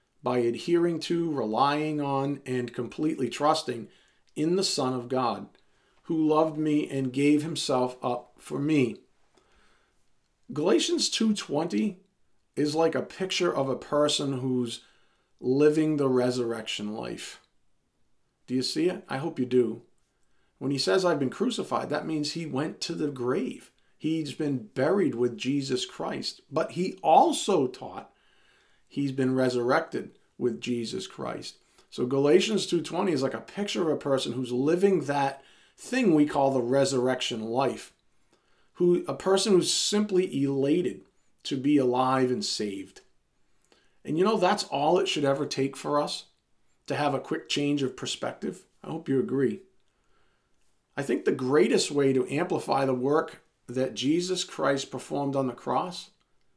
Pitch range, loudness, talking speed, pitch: 130-160 Hz, -27 LUFS, 150 wpm, 140 Hz